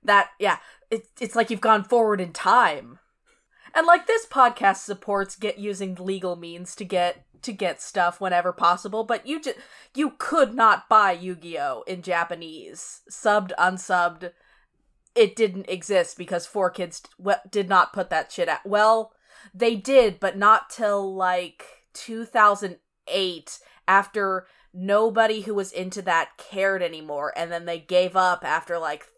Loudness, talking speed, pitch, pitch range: -23 LUFS, 155 wpm, 195 Hz, 180-220 Hz